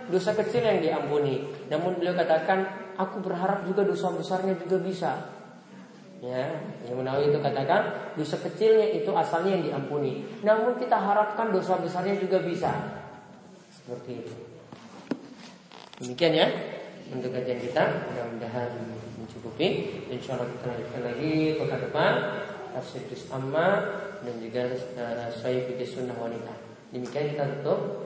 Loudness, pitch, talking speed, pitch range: -28 LUFS, 155 Hz, 125 wpm, 125-190 Hz